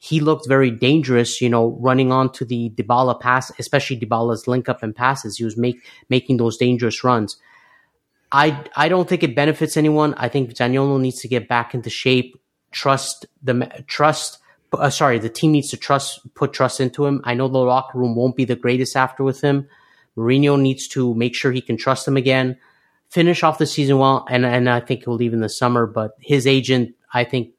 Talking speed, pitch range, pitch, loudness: 205 wpm, 120-140 Hz, 130 Hz, -19 LUFS